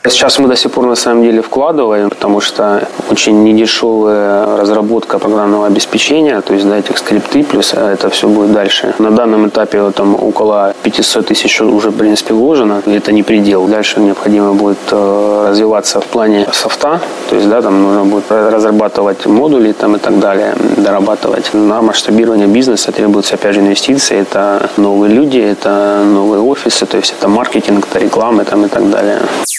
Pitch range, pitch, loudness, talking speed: 100-110 Hz, 105 Hz, -9 LUFS, 175 wpm